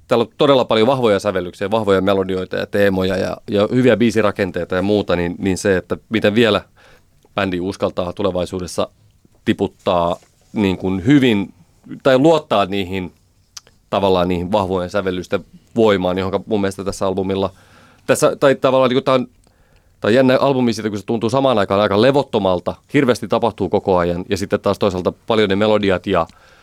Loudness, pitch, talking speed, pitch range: -17 LUFS, 100 Hz, 165 wpm, 95-110 Hz